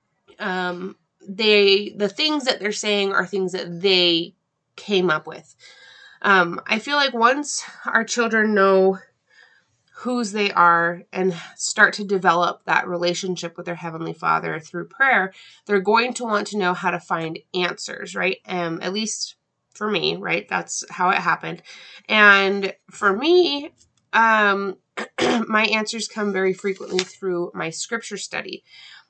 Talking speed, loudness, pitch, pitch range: 145 wpm, -20 LUFS, 195 Hz, 180-220 Hz